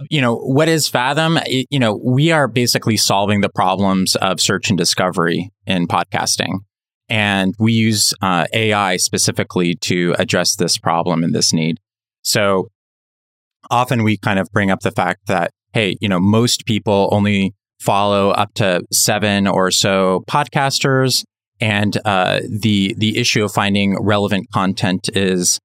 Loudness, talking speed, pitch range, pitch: -16 LUFS, 155 wpm, 95-115 Hz, 105 Hz